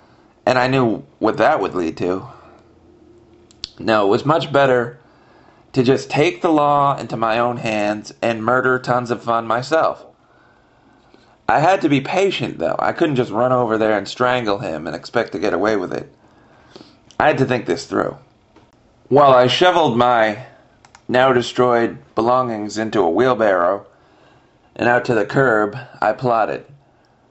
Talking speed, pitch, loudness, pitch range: 160 wpm, 125 Hz, -17 LUFS, 115-130 Hz